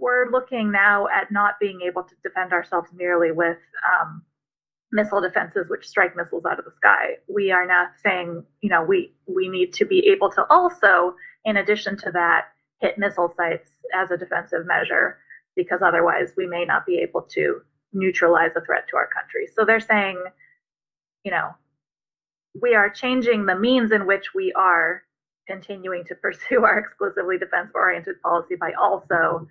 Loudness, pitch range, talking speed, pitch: -21 LUFS, 180-255 Hz, 175 wpm, 200 Hz